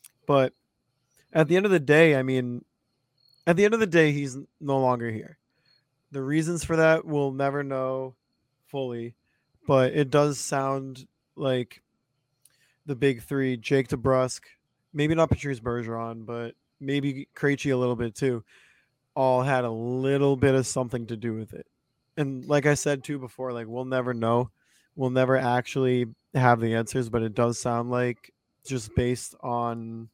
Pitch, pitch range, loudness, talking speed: 130 Hz, 120-140 Hz, -26 LUFS, 160 wpm